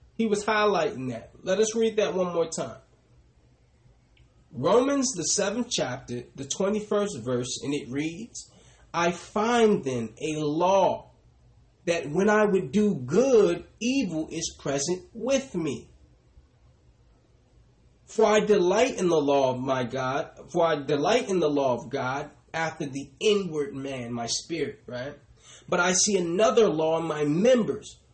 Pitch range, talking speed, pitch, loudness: 135-210 Hz, 150 wpm, 165 Hz, -26 LUFS